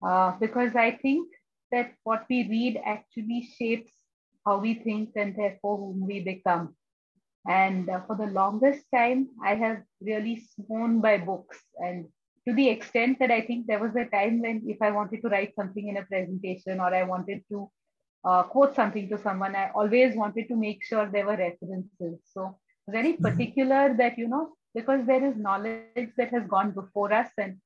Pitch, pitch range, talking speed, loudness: 215 Hz, 195-240 Hz, 185 wpm, -27 LUFS